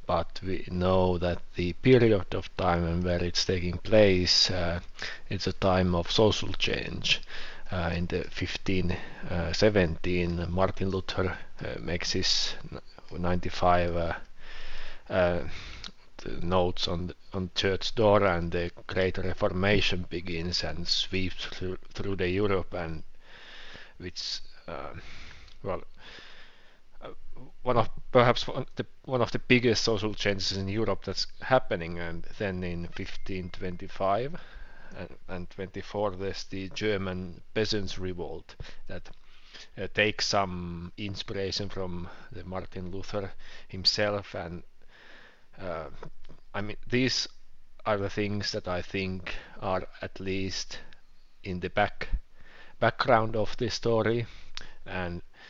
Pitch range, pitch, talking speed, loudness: 90-105 Hz, 95 Hz, 125 wpm, -29 LUFS